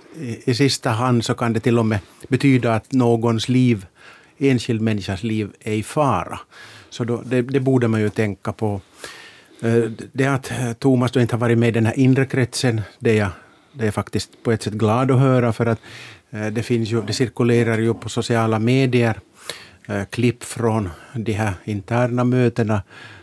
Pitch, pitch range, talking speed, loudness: 115 Hz, 110-125 Hz, 180 wpm, -20 LUFS